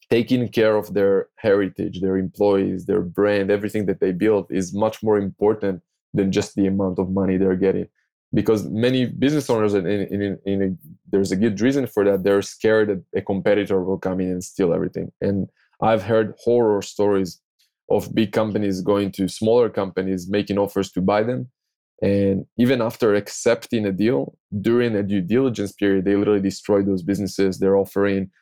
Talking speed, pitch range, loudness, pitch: 175 wpm, 95-110 Hz, -21 LUFS, 100 Hz